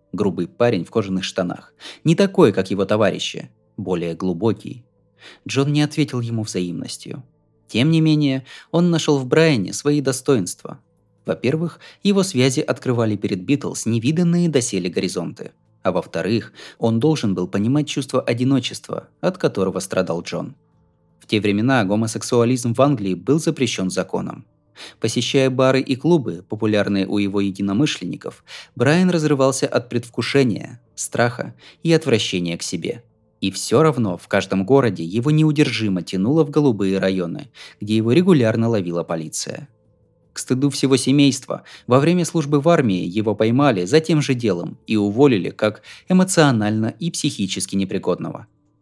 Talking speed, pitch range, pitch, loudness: 140 wpm, 100-145 Hz, 120 Hz, -19 LUFS